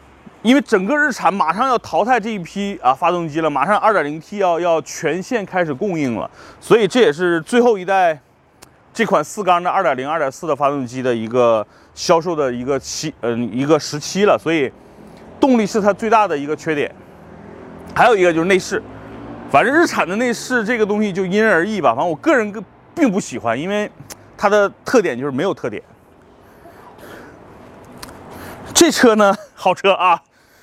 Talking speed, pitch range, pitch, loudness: 270 characters per minute, 155-215 Hz, 190 Hz, -17 LUFS